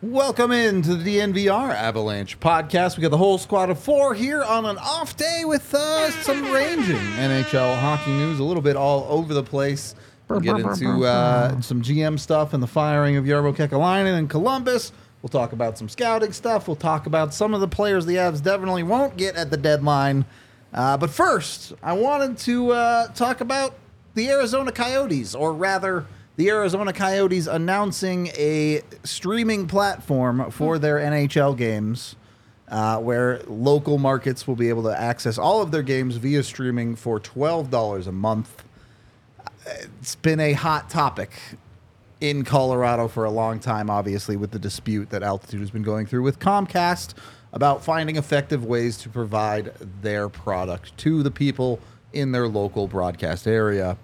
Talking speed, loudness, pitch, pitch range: 170 wpm, -22 LUFS, 145 Hz, 115-190 Hz